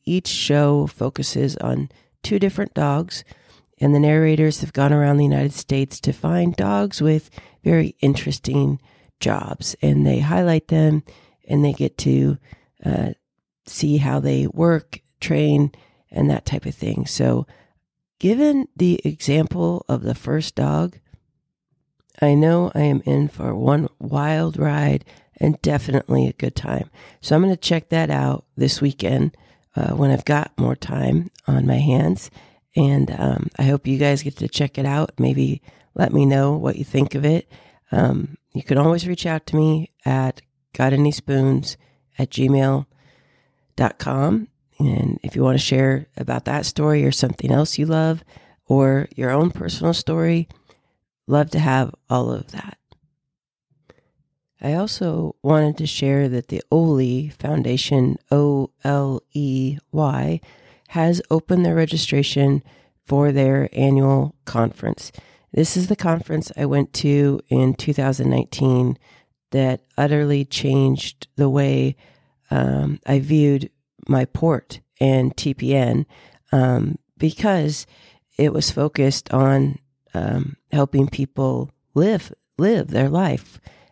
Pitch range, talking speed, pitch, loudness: 130-155 Hz, 140 wpm, 140 Hz, -20 LUFS